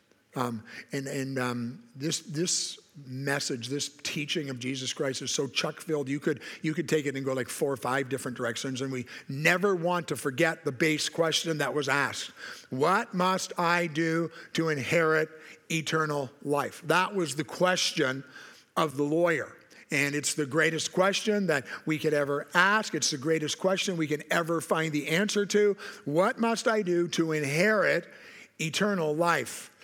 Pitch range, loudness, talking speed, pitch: 140-175 Hz, -28 LUFS, 175 wpm, 155 Hz